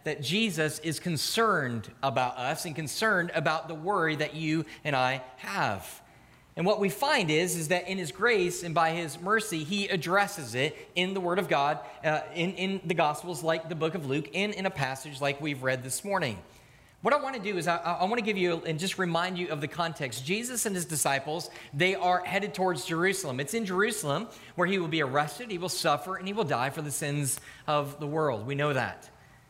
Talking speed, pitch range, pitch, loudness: 220 wpm, 145-190 Hz, 165 Hz, -29 LUFS